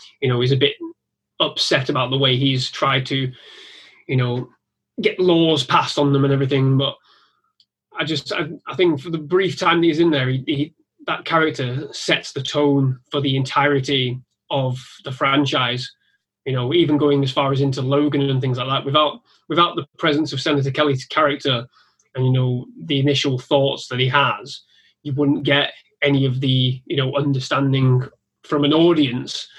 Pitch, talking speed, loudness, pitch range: 140 Hz, 185 wpm, -19 LUFS, 130-150 Hz